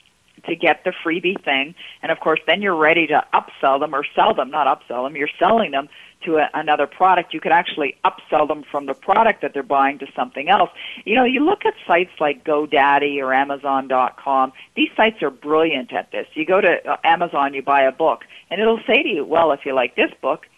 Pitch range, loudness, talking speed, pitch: 140-195 Hz, -18 LUFS, 220 wpm, 155 Hz